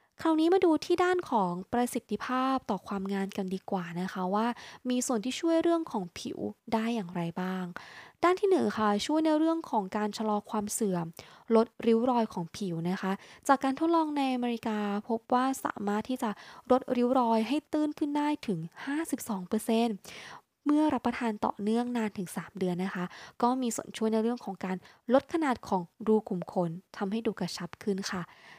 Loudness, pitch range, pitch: -30 LUFS, 195-265 Hz, 225 Hz